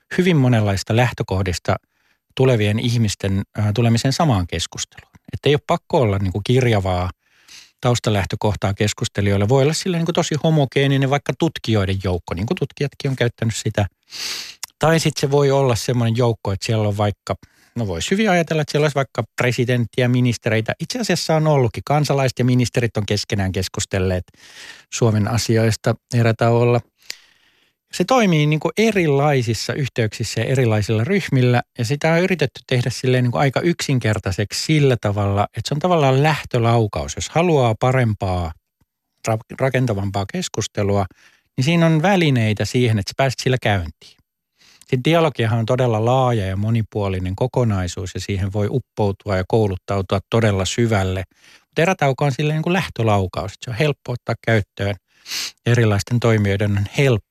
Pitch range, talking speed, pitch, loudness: 105-140 Hz, 150 wpm, 120 Hz, -19 LUFS